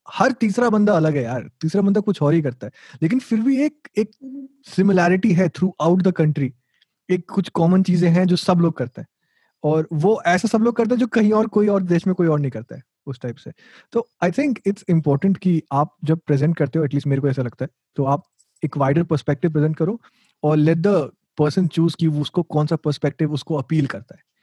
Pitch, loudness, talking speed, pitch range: 170 Hz, -20 LUFS, 230 wpm, 150-200 Hz